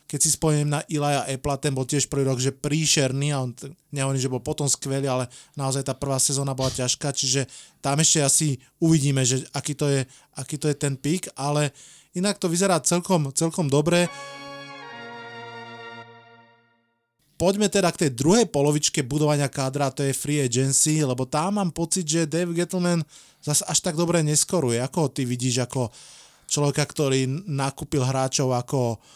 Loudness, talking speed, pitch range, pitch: -23 LUFS, 170 wpm, 130-155 Hz, 145 Hz